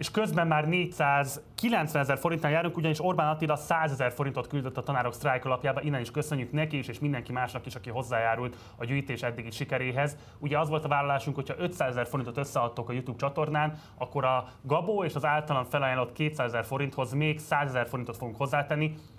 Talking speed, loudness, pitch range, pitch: 195 wpm, -30 LUFS, 125-150 Hz, 140 Hz